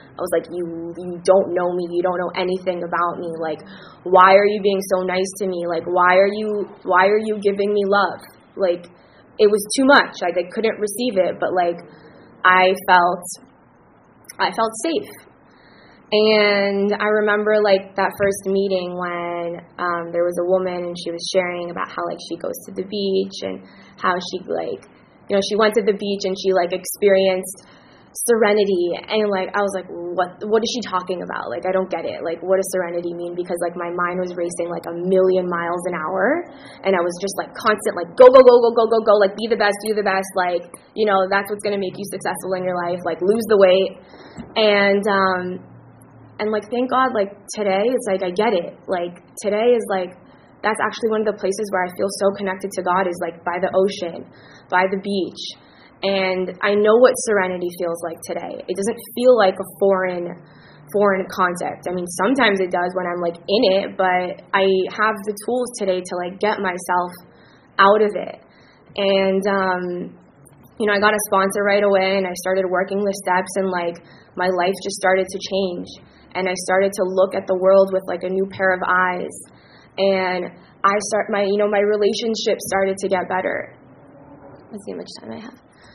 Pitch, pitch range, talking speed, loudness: 190 Hz, 180-205 Hz, 205 wpm, -19 LUFS